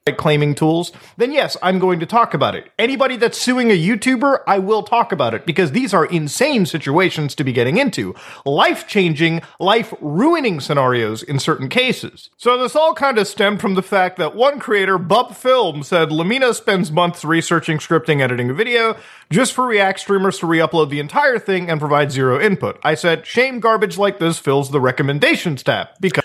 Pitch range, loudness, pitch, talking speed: 155-225 Hz, -16 LUFS, 185 Hz, 185 wpm